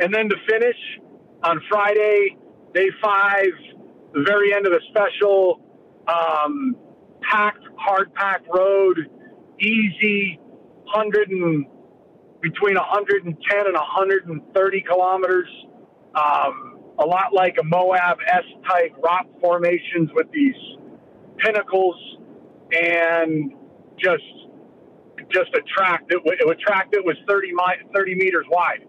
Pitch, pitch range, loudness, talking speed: 190 Hz, 175-205 Hz, -20 LUFS, 125 wpm